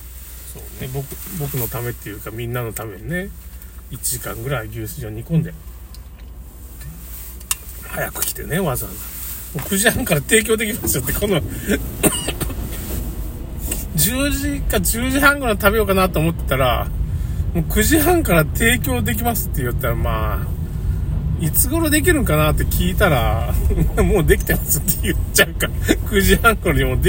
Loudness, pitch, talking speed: -19 LUFS, 90 Hz, 295 characters per minute